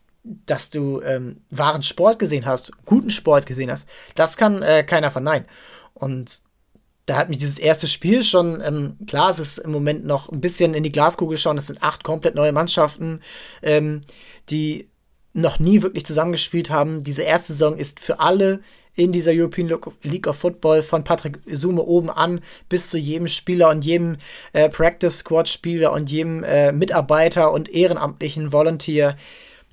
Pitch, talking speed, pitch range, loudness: 160 Hz, 170 wpm, 150-170 Hz, -19 LUFS